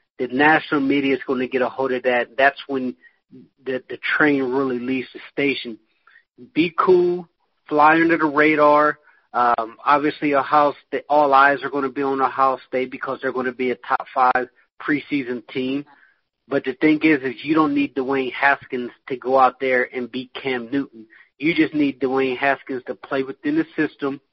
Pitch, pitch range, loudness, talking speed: 135 Hz, 130-145 Hz, -20 LUFS, 190 wpm